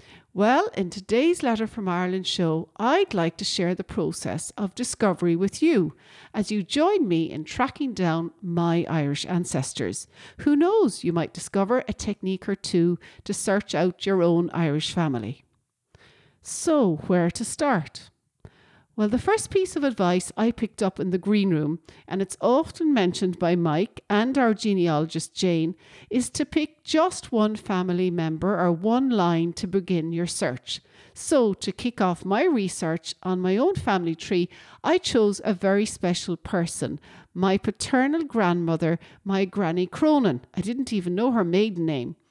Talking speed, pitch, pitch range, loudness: 160 wpm, 190 Hz, 170-225 Hz, -24 LUFS